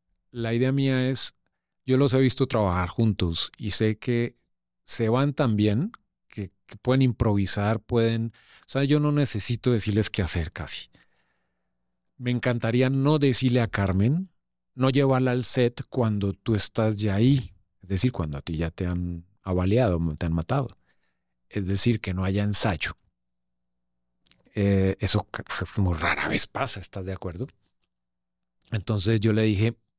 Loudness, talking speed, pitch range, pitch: -25 LUFS, 155 wpm, 90-125 Hz, 105 Hz